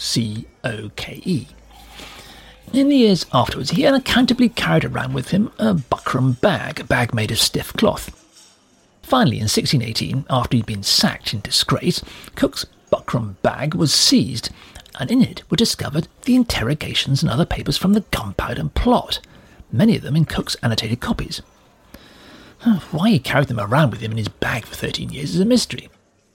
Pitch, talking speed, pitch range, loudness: 145 Hz, 170 wpm, 120-200 Hz, -19 LUFS